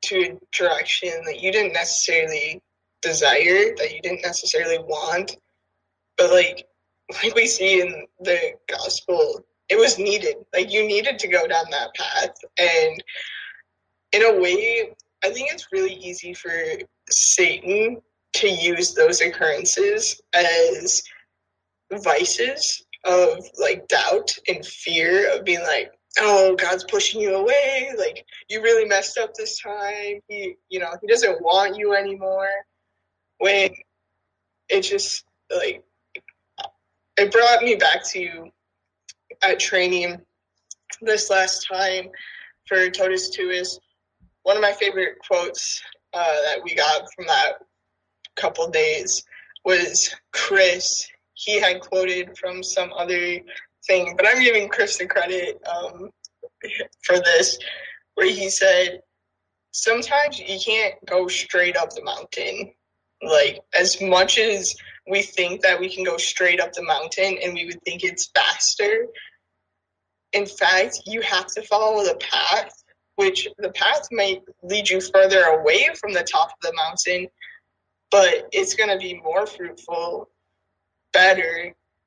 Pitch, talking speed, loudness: 210 Hz, 140 wpm, -20 LUFS